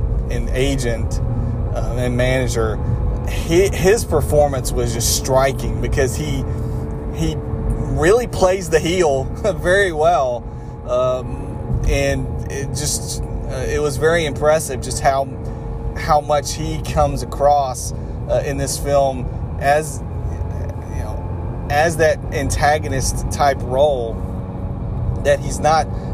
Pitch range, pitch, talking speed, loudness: 110-140 Hz, 120 Hz, 115 wpm, -19 LUFS